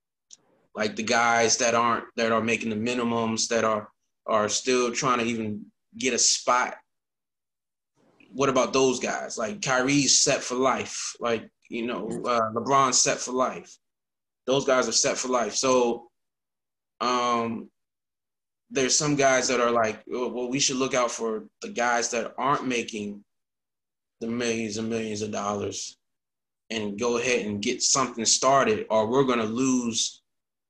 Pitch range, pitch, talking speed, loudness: 110-125 Hz, 115 Hz, 155 wpm, -24 LUFS